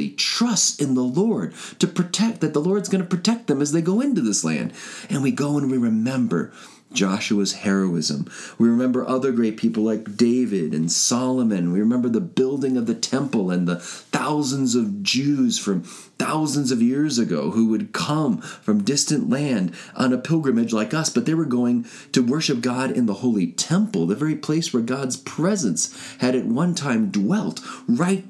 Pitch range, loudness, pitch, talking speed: 120-190 Hz, -21 LUFS, 140 Hz, 185 wpm